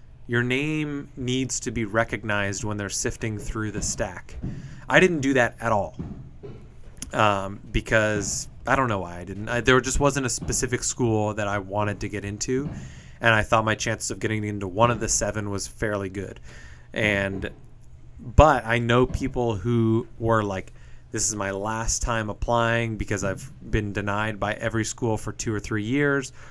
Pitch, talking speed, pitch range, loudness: 110 Hz, 180 wpm, 105-125 Hz, -24 LUFS